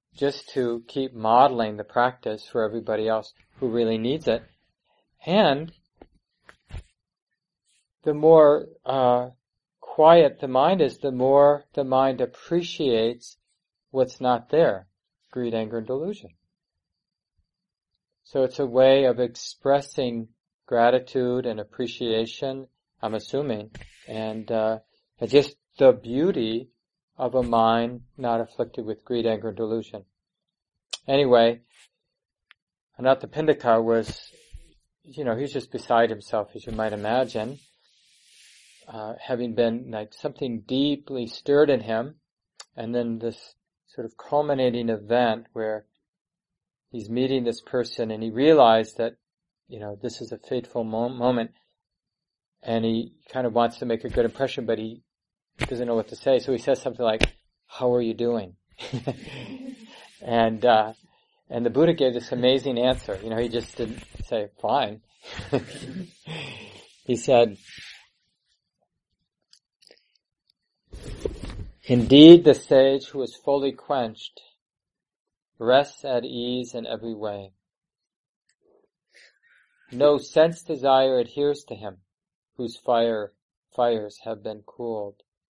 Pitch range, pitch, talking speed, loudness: 115-135 Hz, 120 Hz, 120 wpm, -23 LUFS